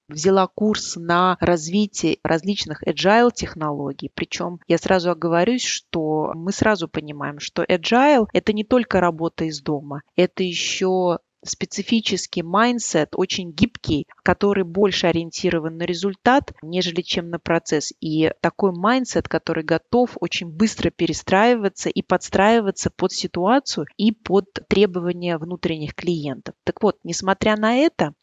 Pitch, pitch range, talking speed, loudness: 180 Hz, 165-205 Hz, 130 wpm, -21 LUFS